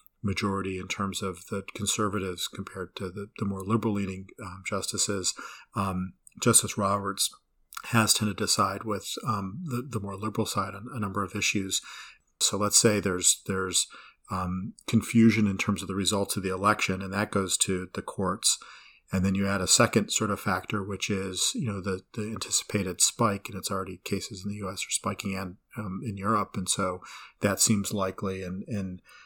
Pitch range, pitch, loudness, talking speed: 95-105 Hz, 100 Hz, -27 LUFS, 190 wpm